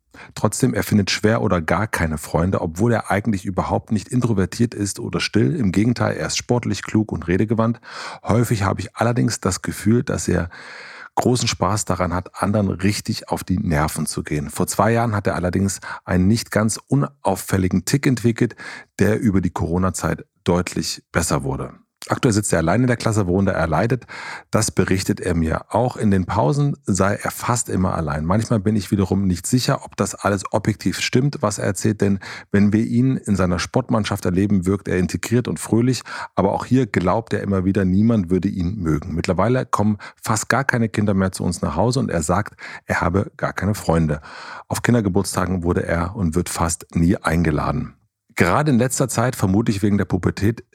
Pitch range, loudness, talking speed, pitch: 90-115 Hz, -20 LUFS, 190 wpm, 100 Hz